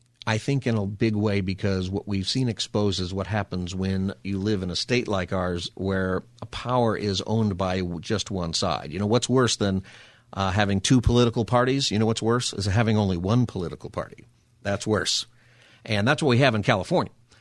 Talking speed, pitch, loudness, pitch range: 205 wpm, 105 Hz, -25 LUFS, 95-120 Hz